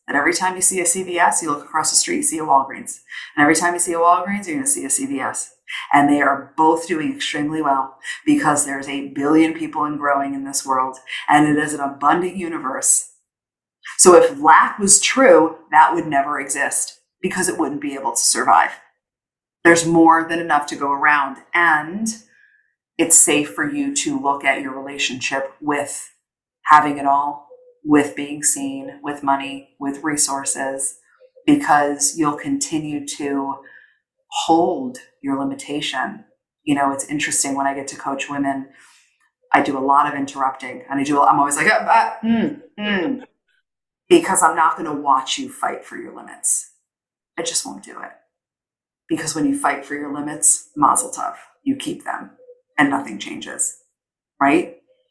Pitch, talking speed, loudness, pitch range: 150 Hz, 175 wpm, -18 LUFS, 140-230 Hz